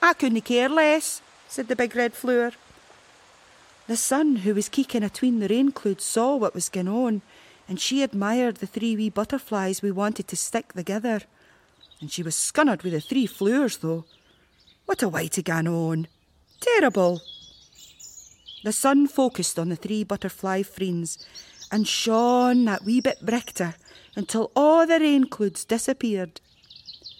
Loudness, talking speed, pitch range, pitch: -24 LUFS, 155 wpm, 190-255 Hz, 220 Hz